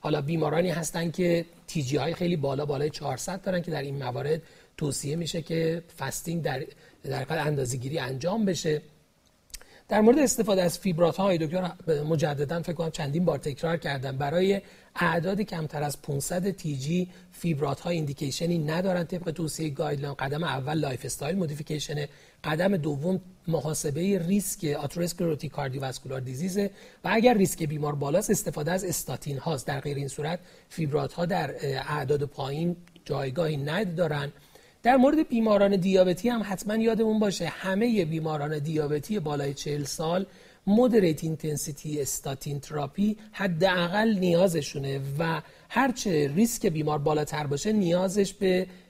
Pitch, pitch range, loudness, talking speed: 165 Hz, 150-185 Hz, -28 LUFS, 140 wpm